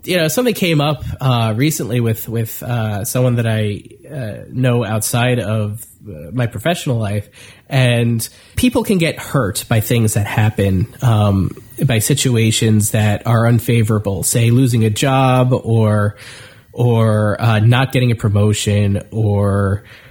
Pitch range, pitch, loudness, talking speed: 105-125 Hz, 115 Hz, -16 LUFS, 140 wpm